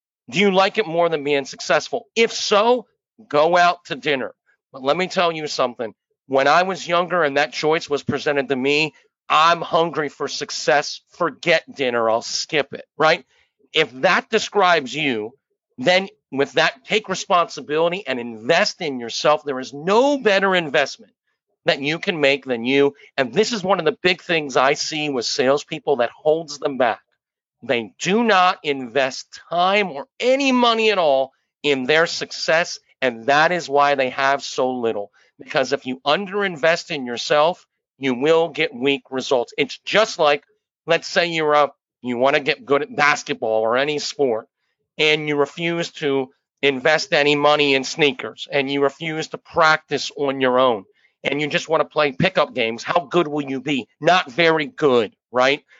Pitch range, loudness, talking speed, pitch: 140-175 Hz, -19 LUFS, 175 wpm, 155 Hz